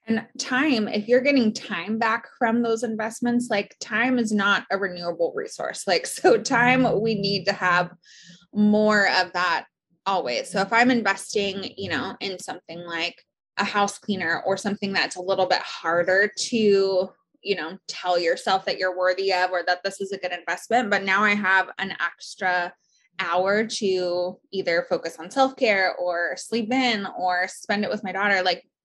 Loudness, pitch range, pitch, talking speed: -23 LUFS, 180-220 Hz, 195 Hz, 180 wpm